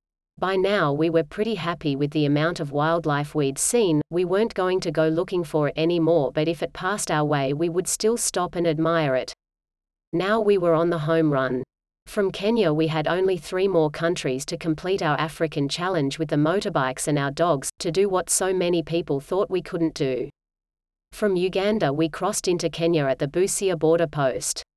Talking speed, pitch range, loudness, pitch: 200 wpm, 155-185 Hz, -23 LUFS, 165 Hz